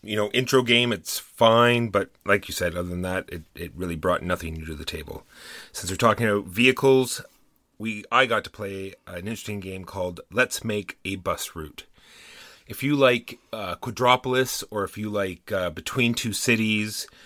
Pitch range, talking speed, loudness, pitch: 90-120 Hz, 190 wpm, -24 LUFS, 105 Hz